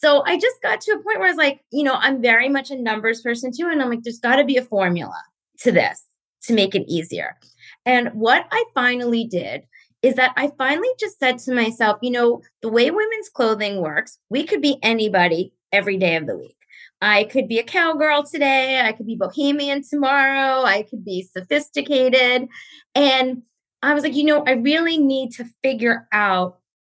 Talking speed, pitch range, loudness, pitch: 205 wpm, 225-285 Hz, -19 LUFS, 255 Hz